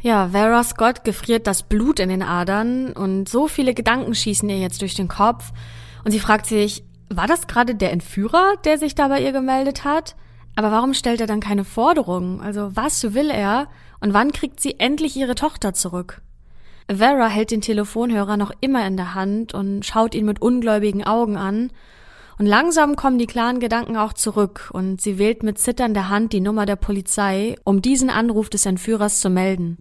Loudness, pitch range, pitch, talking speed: -19 LUFS, 200-245 Hz, 215 Hz, 190 wpm